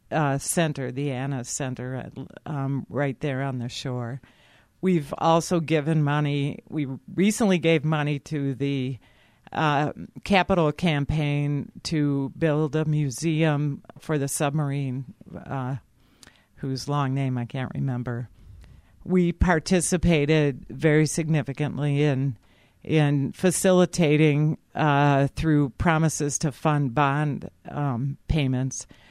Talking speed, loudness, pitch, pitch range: 110 wpm, -24 LUFS, 145 Hz, 135-155 Hz